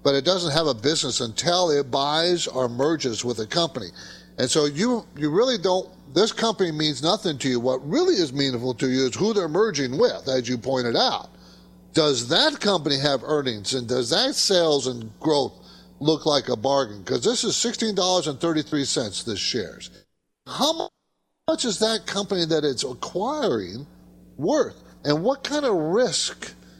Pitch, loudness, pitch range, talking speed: 150 Hz, -23 LUFS, 130-185 Hz, 170 wpm